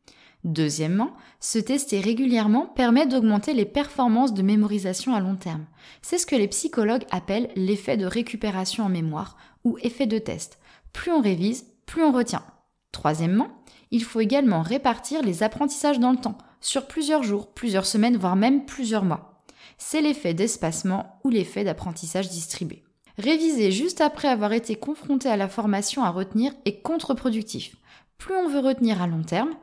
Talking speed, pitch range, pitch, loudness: 160 wpm, 195-270 Hz, 225 Hz, -24 LUFS